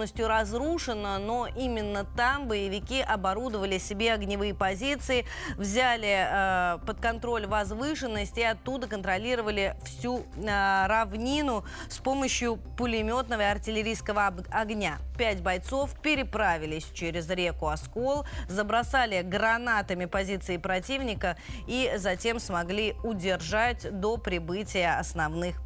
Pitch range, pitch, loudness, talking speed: 195-240 Hz, 215 Hz, -29 LUFS, 100 wpm